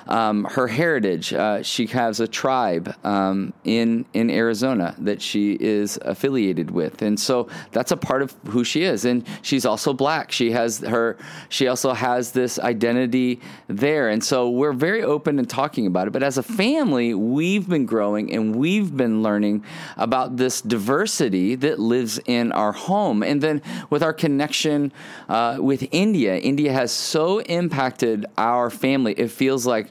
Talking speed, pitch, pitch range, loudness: 170 wpm, 125 Hz, 115-150 Hz, -21 LUFS